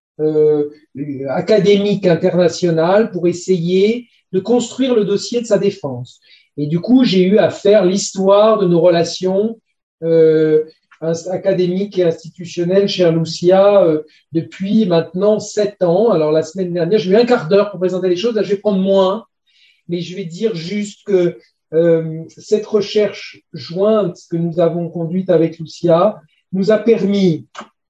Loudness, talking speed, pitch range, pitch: -15 LUFS, 155 wpm, 165-205 Hz, 185 Hz